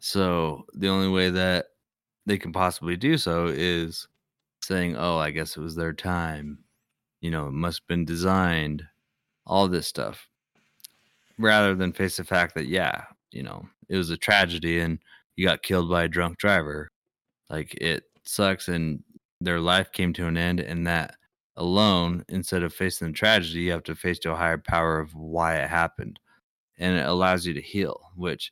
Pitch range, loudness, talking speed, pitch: 80-95 Hz, -25 LUFS, 185 wpm, 85 Hz